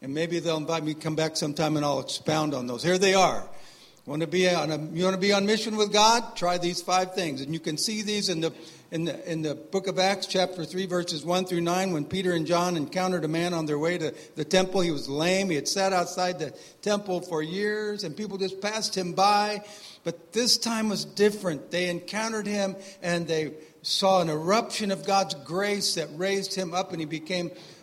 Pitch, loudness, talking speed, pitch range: 180 Hz, -26 LUFS, 230 wpm, 160-195 Hz